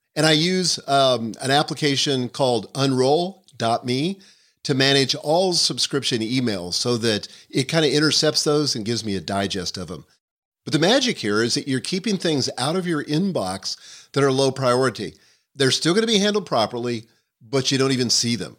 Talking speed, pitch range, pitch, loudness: 185 wpm, 120-155 Hz, 135 Hz, -21 LUFS